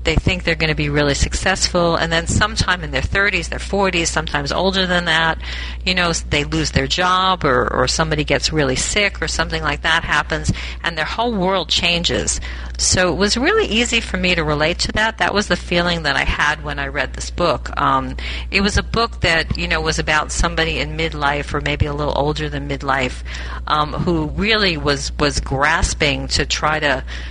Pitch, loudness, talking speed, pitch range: 160 Hz, -17 LUFS, 205 wpm, 145-180 Hz